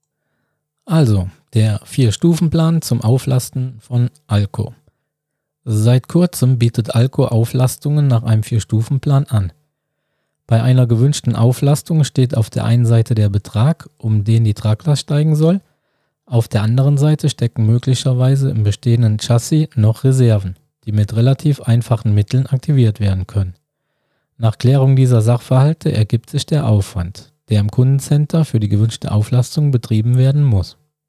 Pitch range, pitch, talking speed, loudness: 110-145 Hz, 125 Hz, 140 wpm, -15 LUFS